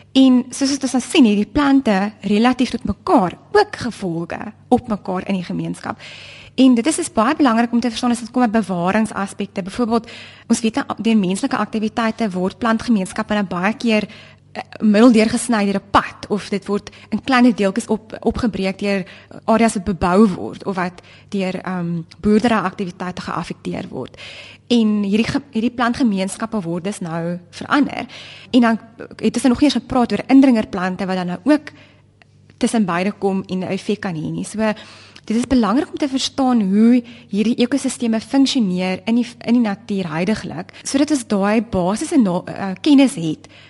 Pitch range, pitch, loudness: 195-245 Hz, 220 Hz, -18 LUFS